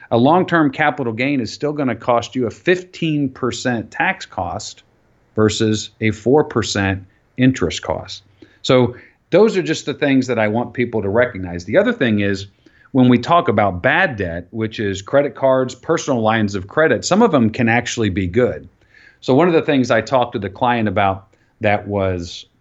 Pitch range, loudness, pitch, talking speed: 105-135 Hz, -17 LUFS, 120 Hz, 185 wpm